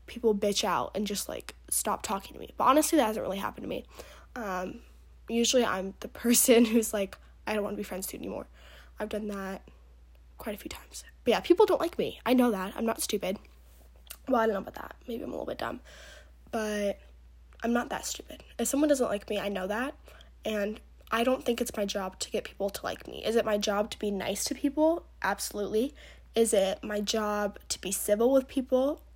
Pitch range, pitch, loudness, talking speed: 195-240 Hz, 210 Hz, -29 LUFS, 225 wpm